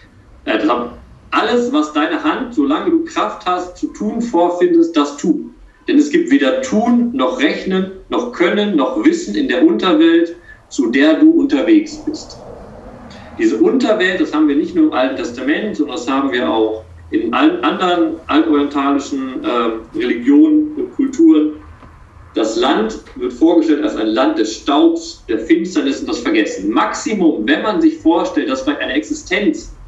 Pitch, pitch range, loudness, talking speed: 310 Hz, 240-325 Hz, -15 LUFS, 160 wpm